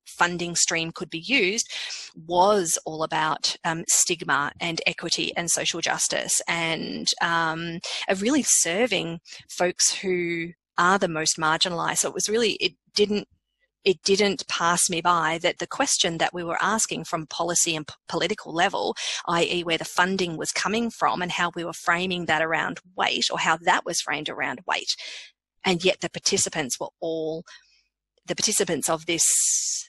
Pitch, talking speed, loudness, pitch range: 175 Hz, 165 wpm, -23 LUFS, 165-195 Hz